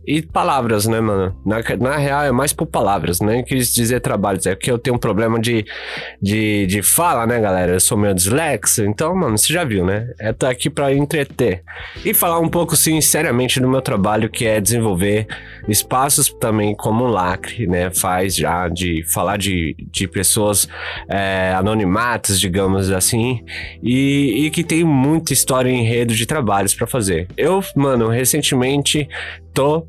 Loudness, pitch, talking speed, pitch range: -16 LUFS, 115 Hz, 175 wpm, 95-135 Hz